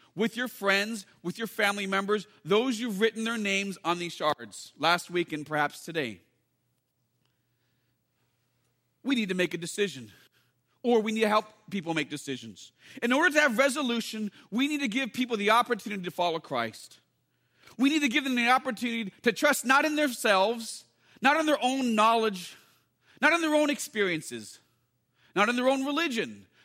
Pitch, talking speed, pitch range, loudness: 205 Hz, 170 wpm, 150-245 Hz, -27 LUFS